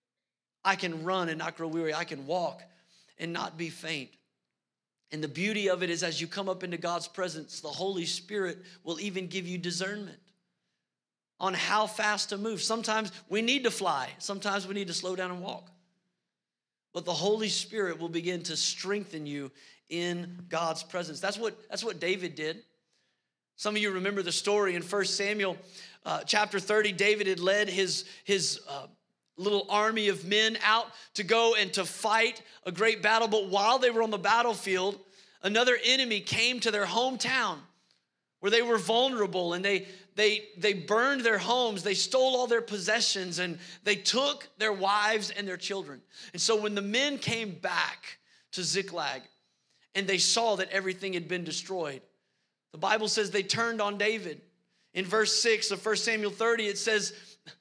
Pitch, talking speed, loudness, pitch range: 195 Hz, 180 wpm, -29 LUFS, 180-215 Hz